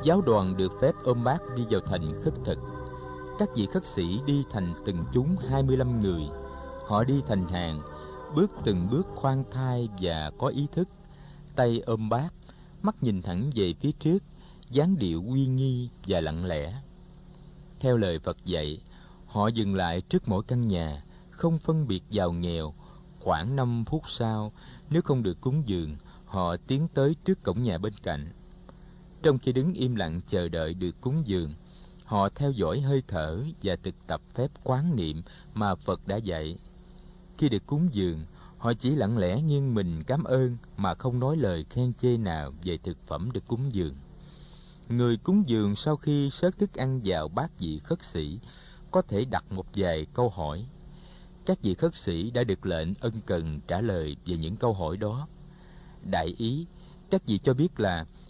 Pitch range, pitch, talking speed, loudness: 90-155 Hz, 120 Hz, 180 wpm, -29 LUFS